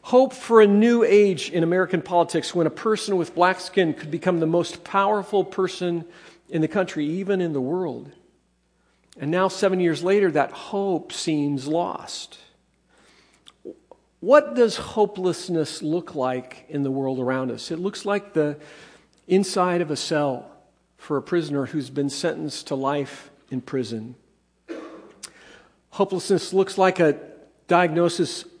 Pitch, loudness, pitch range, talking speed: 175 Hz, -23 LUFS, 150-190 Hz, 145 wpm